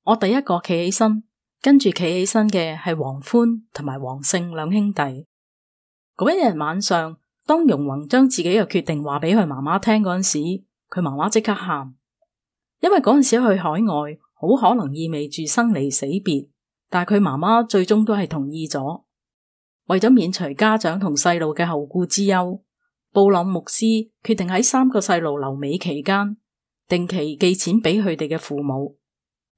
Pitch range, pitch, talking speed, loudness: 155-215 Hz, 180 Hz, 245 characters per minute, -19 LUFS